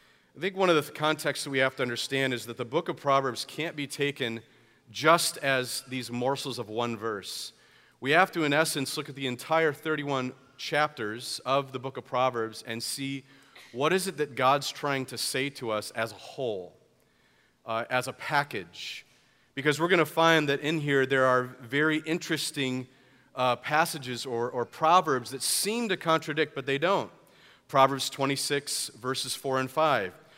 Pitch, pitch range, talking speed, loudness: 135 Hz, 125-150 Hz, 180 wpm, -28 LUFS